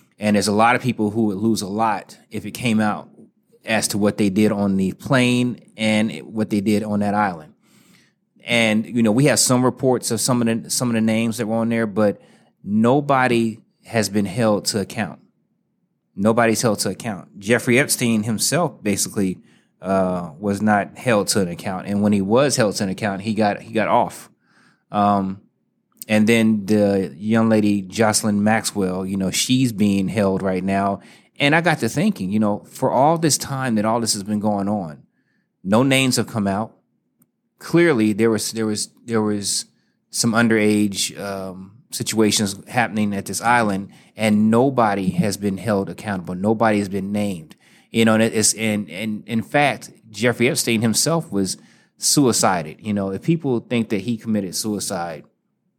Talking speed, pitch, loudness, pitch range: 185 wpm, 110 Hz, -19 LUFS, 100-115 Hz